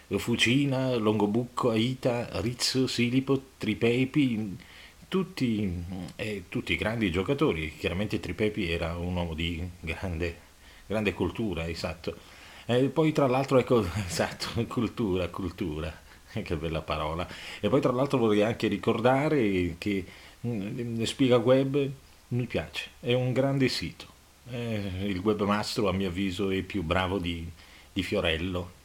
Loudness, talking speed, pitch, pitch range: -28 LUFS, 125 wpm, 105 Hz, 90-120 Hz